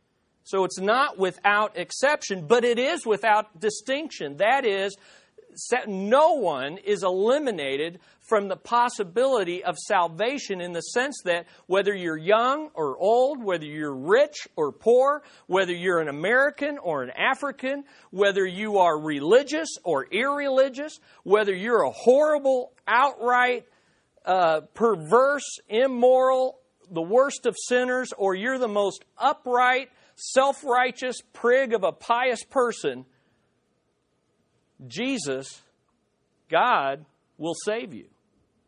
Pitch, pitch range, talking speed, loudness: 230 Hz, 185-260 Hz, 120 wpm, -24 LUFS